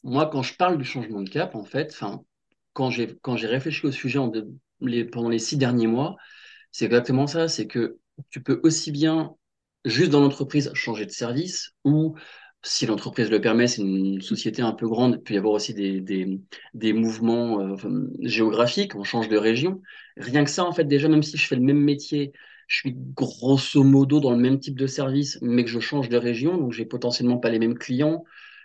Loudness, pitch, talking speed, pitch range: -23 LUFS, 125 Hz, 220 wpm, 115-150 Hz